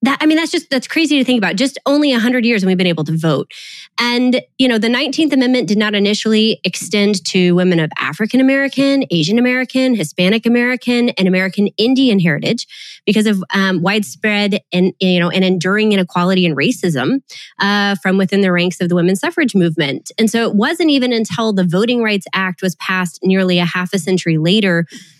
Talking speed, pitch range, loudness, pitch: 200 wpm, 185-245 Hz, -14 LUFS, 205 Hz